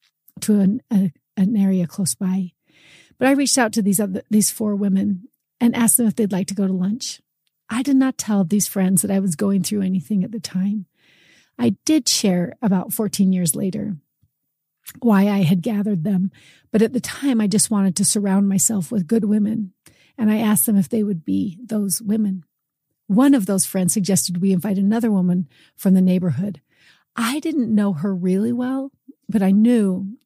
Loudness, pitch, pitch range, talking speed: -19 LUFS, 200 Hz, 190-225 Hz, 195 wpm